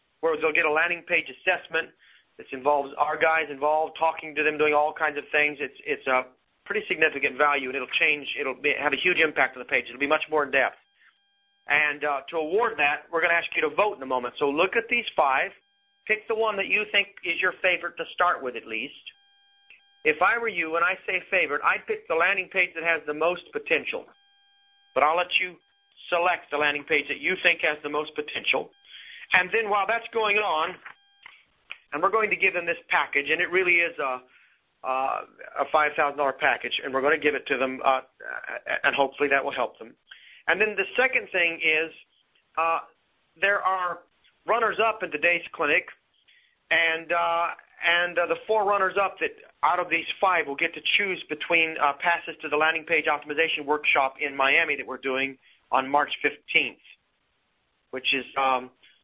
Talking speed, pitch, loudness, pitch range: 205 wpm, 165 Hz, -24 LUFS, 145-195 Hz